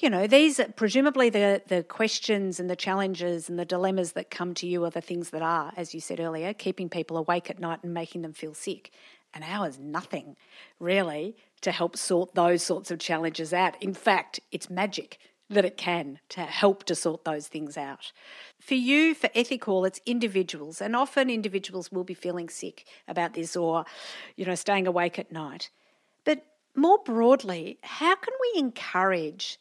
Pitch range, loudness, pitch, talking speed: 170-215 Hz, -27 LUFS, 185 Hz, 185 wpm